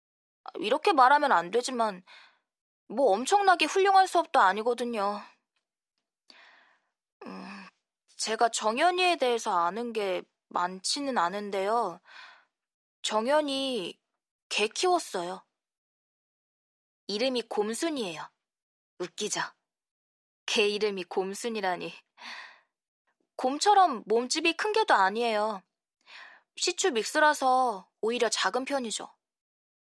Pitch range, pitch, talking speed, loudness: 205-335 Hz, 235 Hz, 200 characters per minute, -27 LUFS